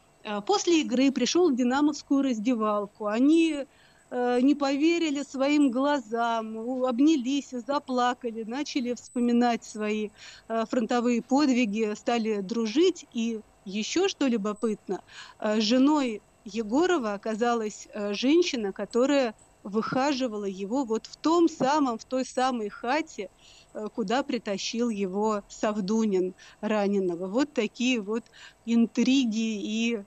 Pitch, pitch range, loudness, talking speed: 240 Hz, 215-275 Hz, -27 LUFS, 110 wpm